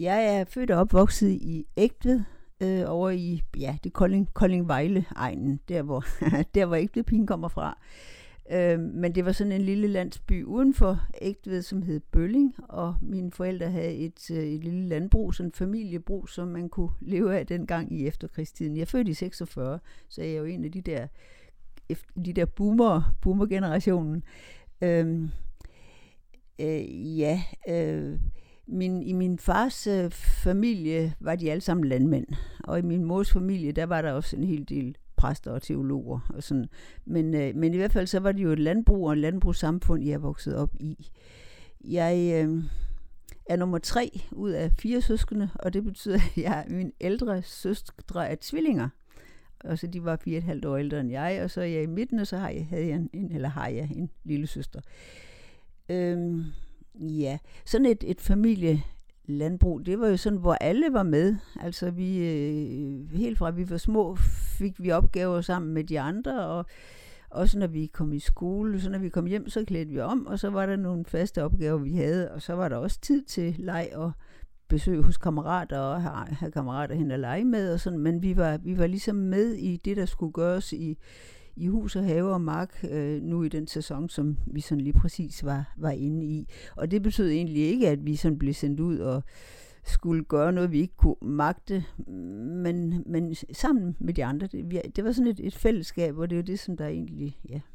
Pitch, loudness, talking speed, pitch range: 170 Hz, -28 LUFS, 200 wpm, 155-190 Hz